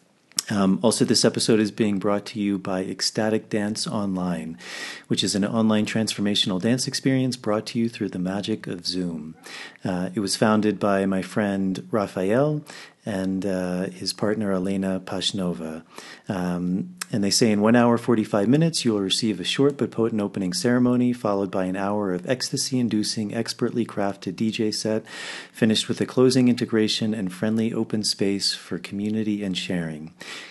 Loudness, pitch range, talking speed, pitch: -23 LUFS, 95-115 Hz, 165 wpm, 105 Hz